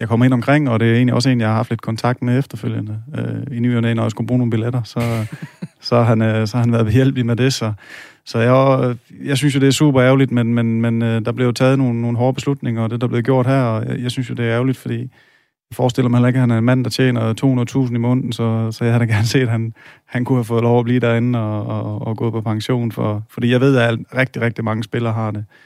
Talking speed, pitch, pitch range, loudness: 280 wpm, 120 Hz, 115-130 Hz, -17 LUFS